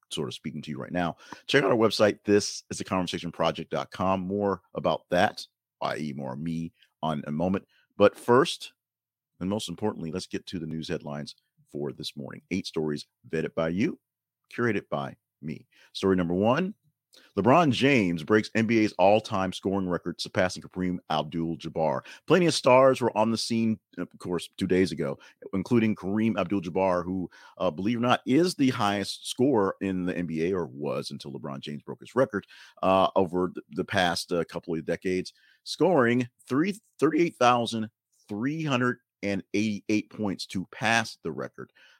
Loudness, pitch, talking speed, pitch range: -27 LUFS, 95 Hz, 170 wpm, 85-110 Hz